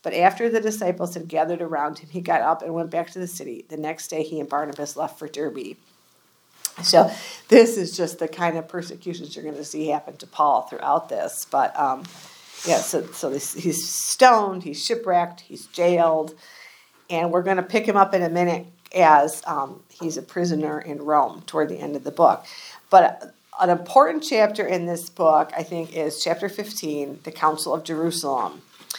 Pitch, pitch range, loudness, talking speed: 170 Hz, 155-180 Hz, -22 LUFS, 195 wpm